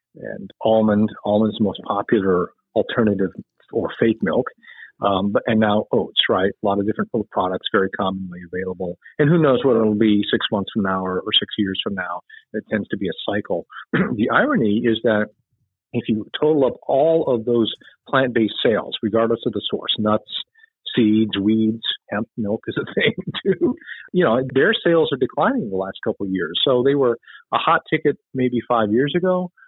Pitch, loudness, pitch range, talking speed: 110 Hz, -20 LUFS, 105-135 Hz, 190 wpm